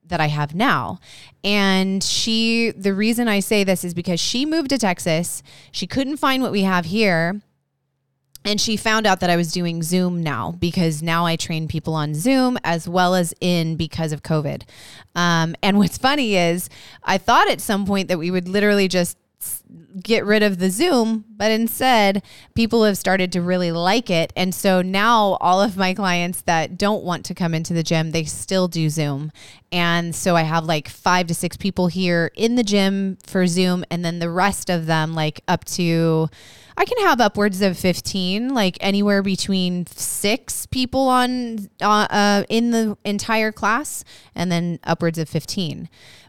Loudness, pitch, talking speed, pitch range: -20 LUFS, 185 Hz, 185 wpm, 165-205 Hz